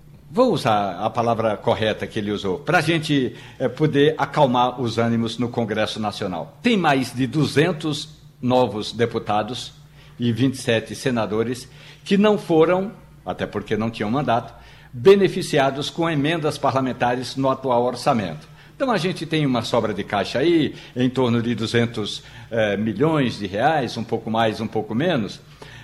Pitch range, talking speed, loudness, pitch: 115-150 Hz, 150 wpm, -21 LUFS, 125 Hz